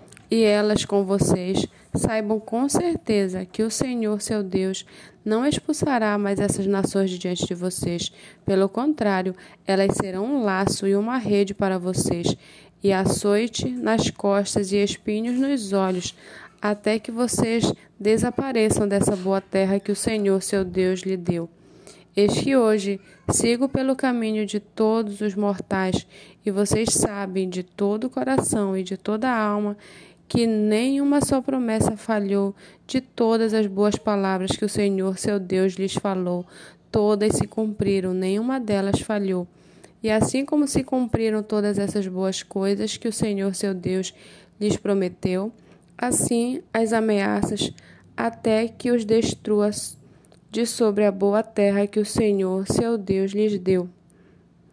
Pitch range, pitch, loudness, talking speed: 190-220 Hz, 205 Hz, -23 LUFS, 145 wpm